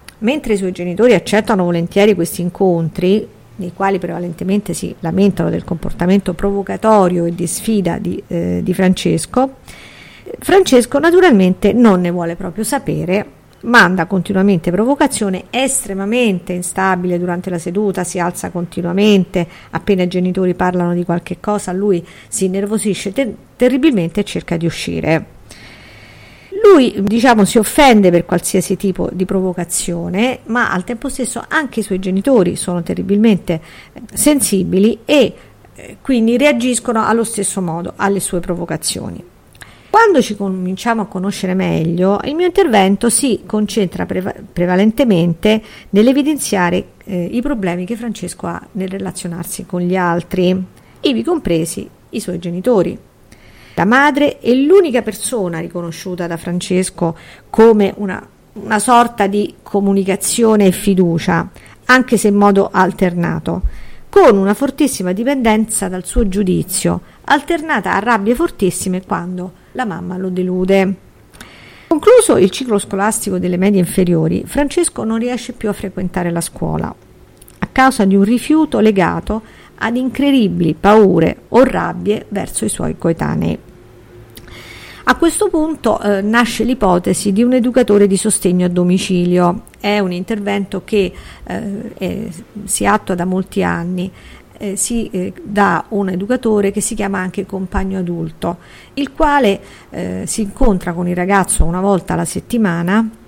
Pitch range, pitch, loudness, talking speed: 180-225 Hz, 195 Hz, -15 LUFS, 135 wpm